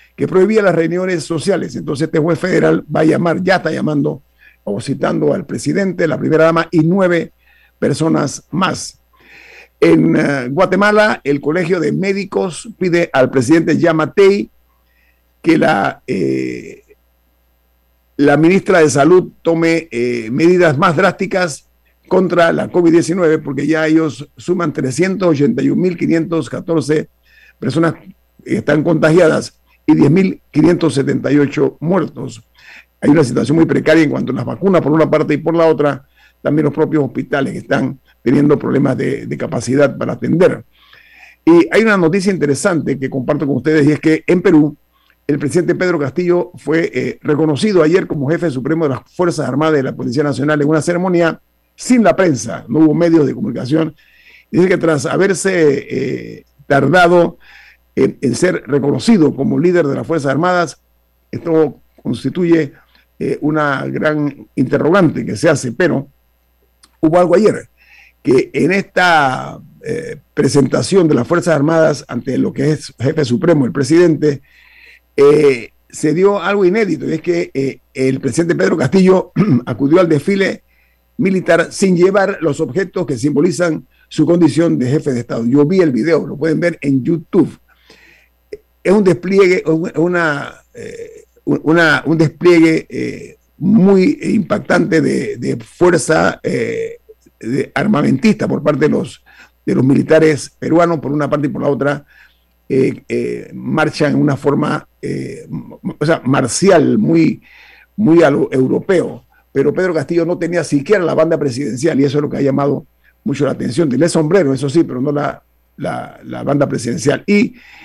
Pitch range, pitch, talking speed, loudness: 145-180 Hz, 160 Hz, 150 wpm, -14 LUFS